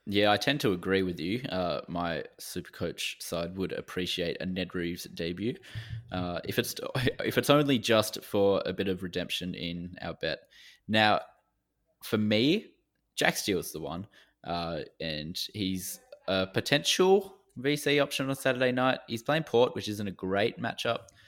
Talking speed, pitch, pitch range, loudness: 165 wpm, 100 Hz, 90-130 Hz, -30 LUFS